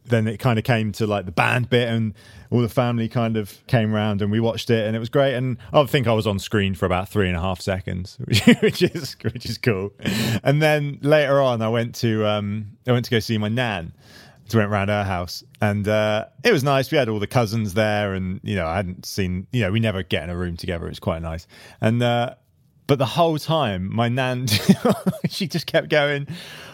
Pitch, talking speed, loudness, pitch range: 115 Hz, 240 wpm, -21 LUFS, 105-130 Hz